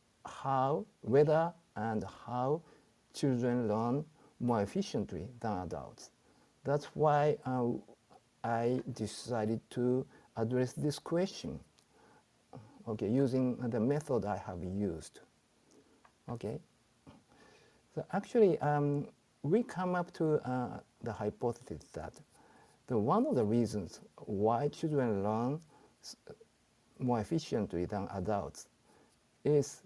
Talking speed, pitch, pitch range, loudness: 105 wpm, 125 Hz, 110-150 Hz, -35 LUFS